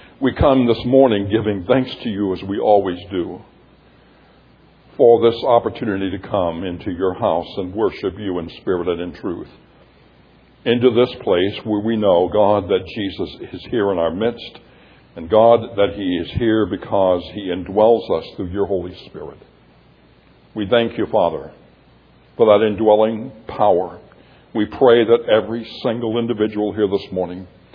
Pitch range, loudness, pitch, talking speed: 95-115 Hz, -18 LUFS, 105 Hz, 160 wpm